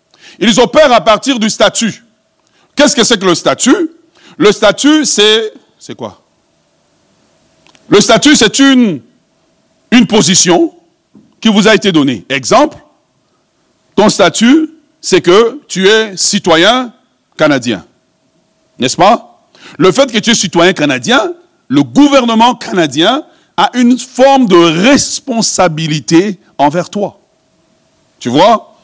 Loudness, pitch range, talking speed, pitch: -8 LUFS, 200-290 Hz, 120 wpm, 230 Hz